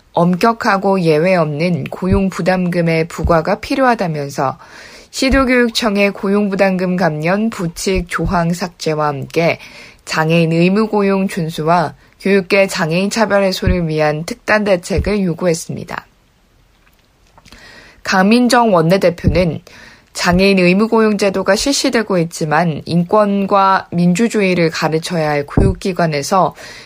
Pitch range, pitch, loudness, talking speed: 165-200 Hz, 185 Hz, -14 LUFS, 275 characters per minute